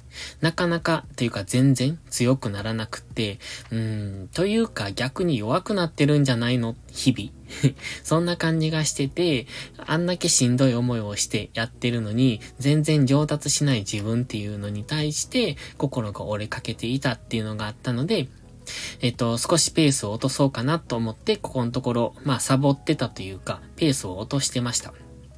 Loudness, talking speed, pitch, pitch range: -24 LUFS, 360 characters per minute, 125 Hz, 115-150 Hz